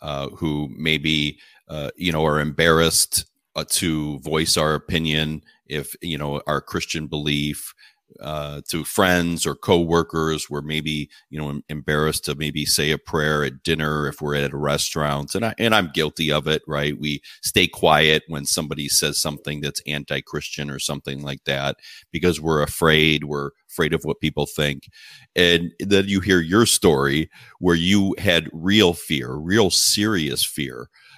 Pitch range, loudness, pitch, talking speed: 75-85 Hz, -21 LUFS, 75 Hz, 165 wpm